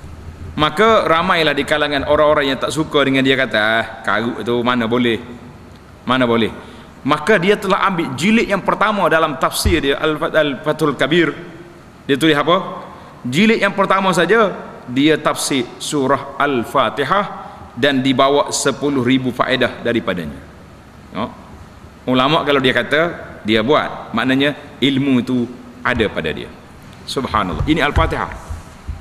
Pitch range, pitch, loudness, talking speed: 120-165 Hz, 140 Hz, -16 LUFS, 125 wpm